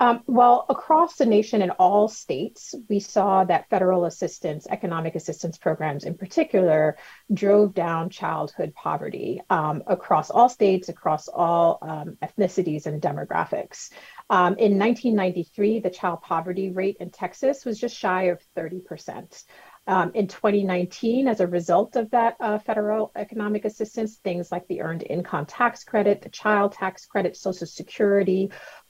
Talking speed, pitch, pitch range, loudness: 145 wpm, 195 Hz, 175-220 Hz, -23 LUFS